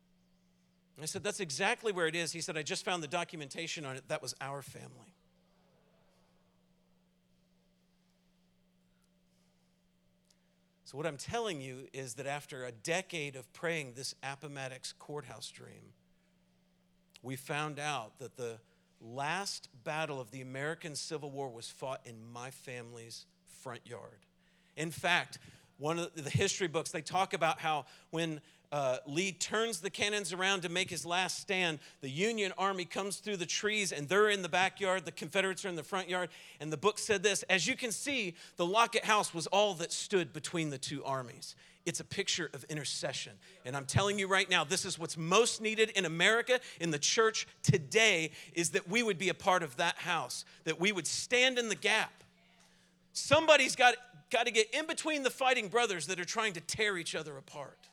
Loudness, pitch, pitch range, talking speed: -33 LUFS, 170 Hz, 140-195 Hz, 180 wpm